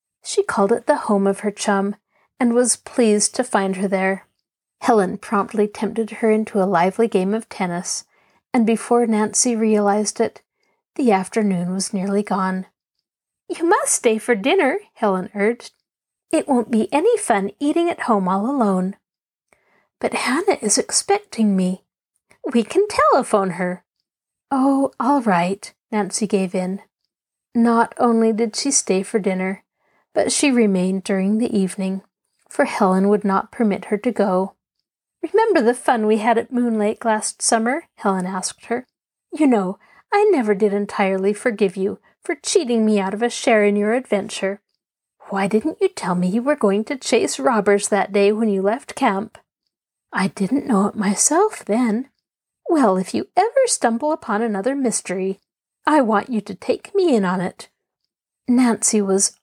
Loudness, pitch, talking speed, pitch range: -19 LUFS, 215 Hz, 165 wpm, 195-250 Hz